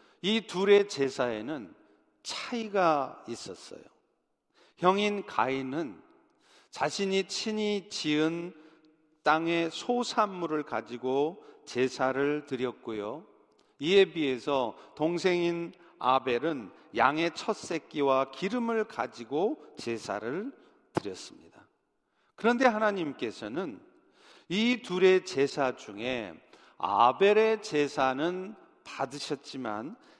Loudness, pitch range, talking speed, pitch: -29 LUFS, 135-205 Hz, 200 characters per minute, 165 Hz